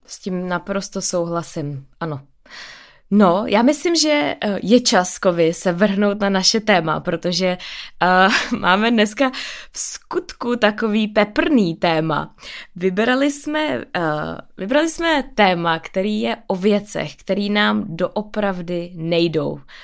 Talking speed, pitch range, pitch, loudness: 120 wpm, 175-225 Hz, 200 Hz, -18 LUFS